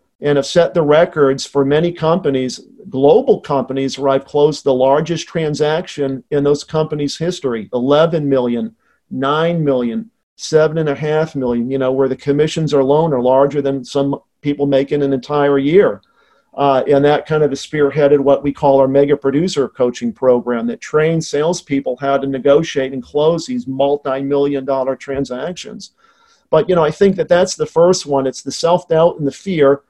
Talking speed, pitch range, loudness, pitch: 170 wpm, 135-155 Hz, -15 LUFS, 145 Hz